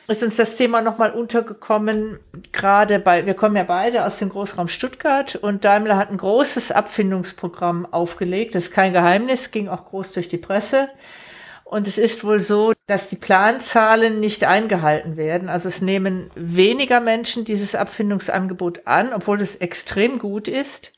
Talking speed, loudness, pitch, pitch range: 165 wpm, -19 LUFS, 205 Hz, 185-225 Hz